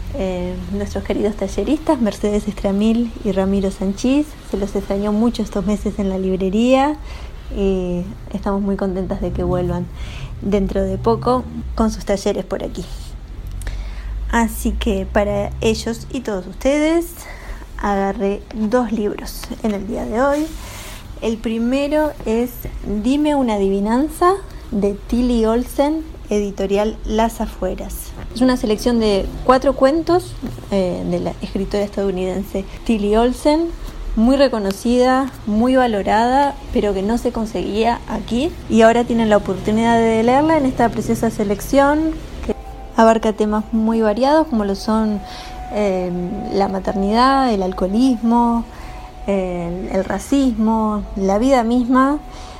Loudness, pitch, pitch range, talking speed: -18 LUFS, 215 Hz, 195-245 Hz, 130 wpm